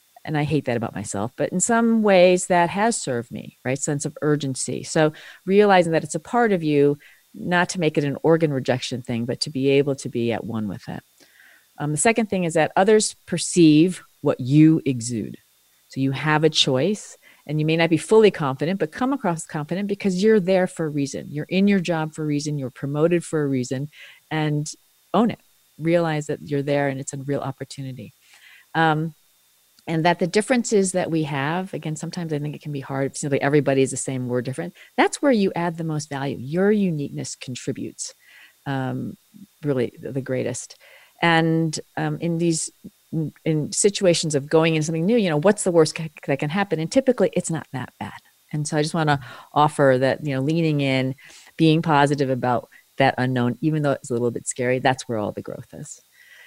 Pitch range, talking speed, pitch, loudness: 135-175 Hz, 205 wpm, 155 Hz, -22 LUFS